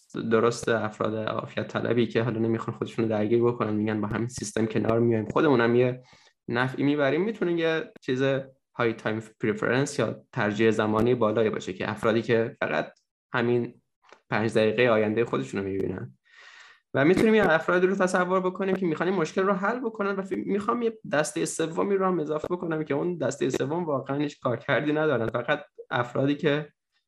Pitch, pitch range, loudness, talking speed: 130 Hz, 115-170 Hz, -26 LUFS, 165 wpm